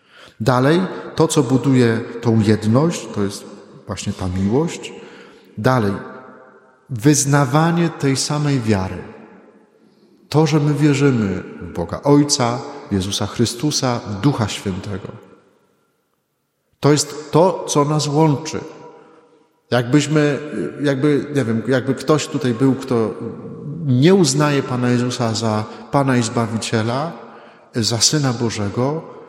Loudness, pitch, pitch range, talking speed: -18 LUFS, 130 Hz, 115-150 Hz, 110 wpm